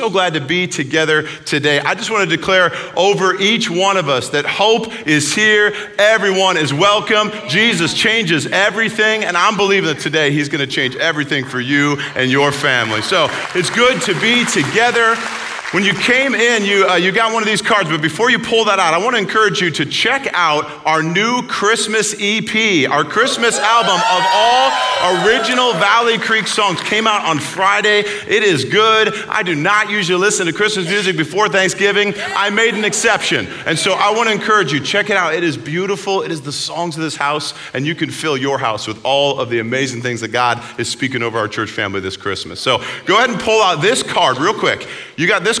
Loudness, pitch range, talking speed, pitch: -14 LUFS, 155-215 Hz, 215 wpm, 195 Hz